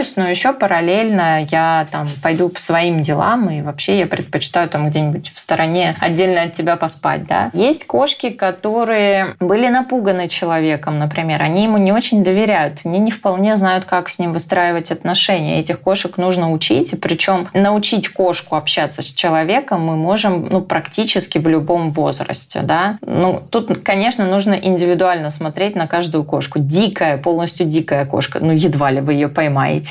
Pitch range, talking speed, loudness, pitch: 160-195 Hz, 165 wpm, -16 LUFS, 175 Hz